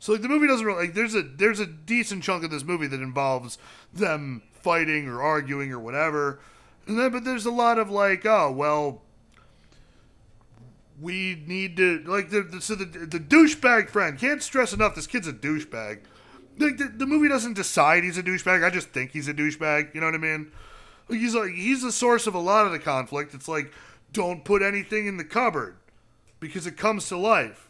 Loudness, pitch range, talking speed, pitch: -24 LUFS, 150-220 Hz, 210 wpm, 185 Hz